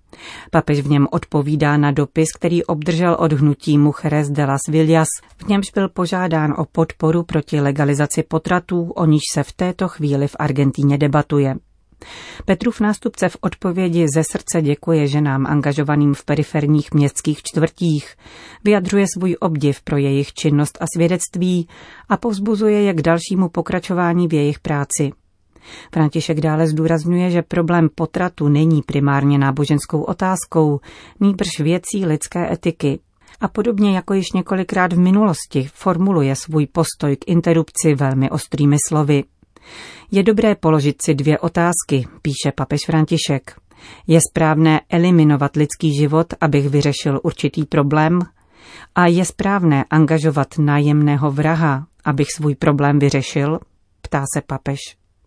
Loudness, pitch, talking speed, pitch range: -17 LUFS, 155 Hz, 130 wpm, 145-175 Hz